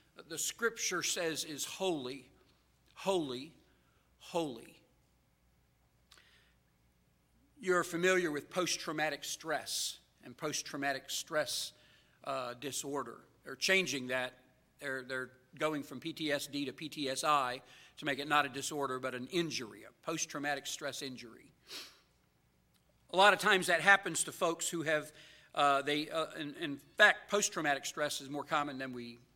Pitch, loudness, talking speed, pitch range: 145 Hz, -34 LUFS, 135 wpm, 130-165 Hz